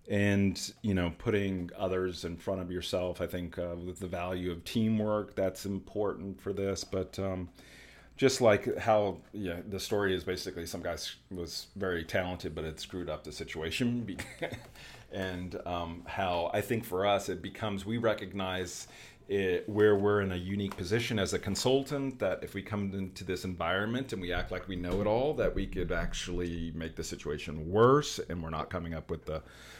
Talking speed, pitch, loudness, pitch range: 185 wpm, 95 Hz, -33 LUFS, 85-100 Hz